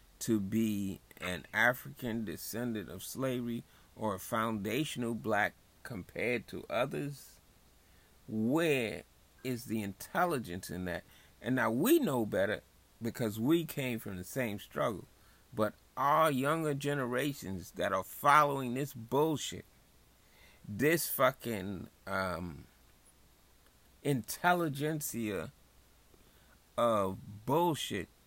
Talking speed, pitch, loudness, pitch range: 100 wpm, 110 Hz, -34 LUFS, 95-135 Hz